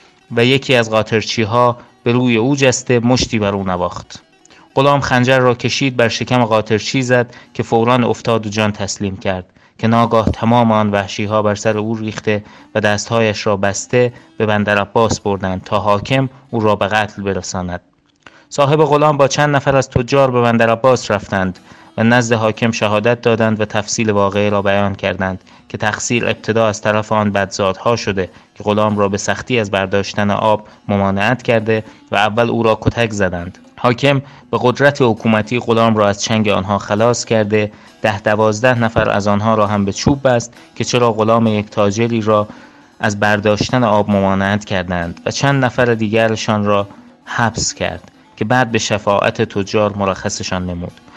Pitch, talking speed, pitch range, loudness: 110 Hz, 170 wpm, 105-120 Hz, -15 LUFS